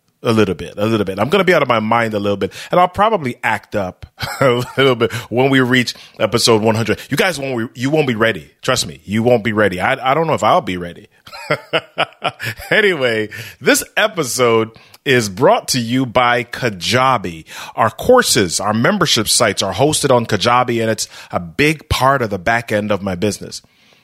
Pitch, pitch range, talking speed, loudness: 115 Hz, 105-130 Hz, 200 wpm, -15 LUFS